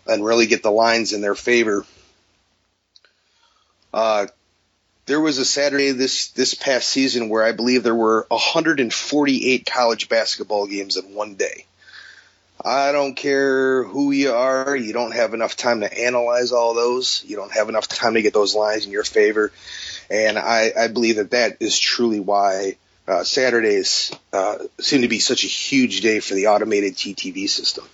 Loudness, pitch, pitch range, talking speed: -19 LUFS, 120 Hz, 105-140 Hz, 170 wpm